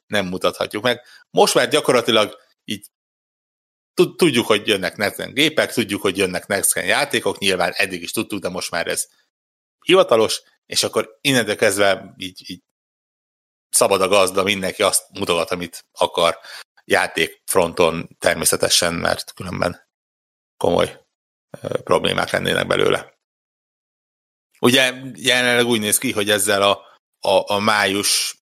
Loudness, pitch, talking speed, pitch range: -18 LUFS, 105 Hz, 125 wpm, 95-130 Hz